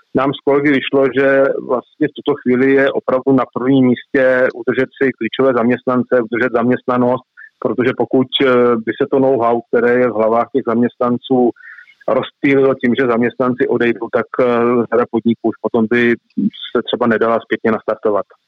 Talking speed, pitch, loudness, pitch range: 155 wpm, 125 Hz, -15 LUFS, 120-135 Hz